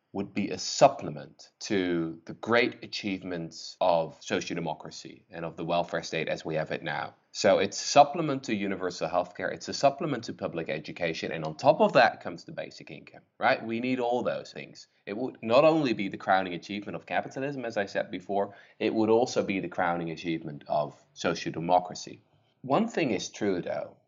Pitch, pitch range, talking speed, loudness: 100 Hz, 85-115 Hz, 195 wpm, -28 LUFS